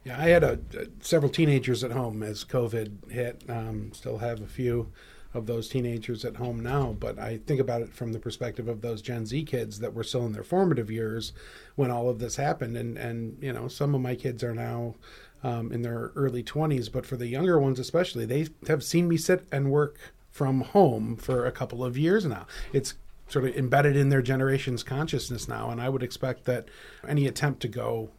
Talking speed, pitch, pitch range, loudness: 215 wpm, 125 Hz, 115-140 Hz, -28 LUFS